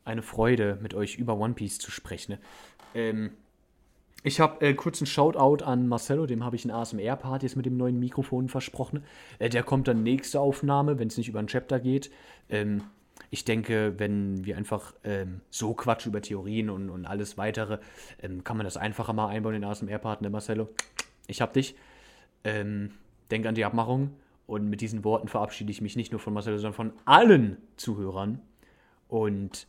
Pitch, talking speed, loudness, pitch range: 110 Hz, 190 wpm, -28 LUFS, 105-125 Hz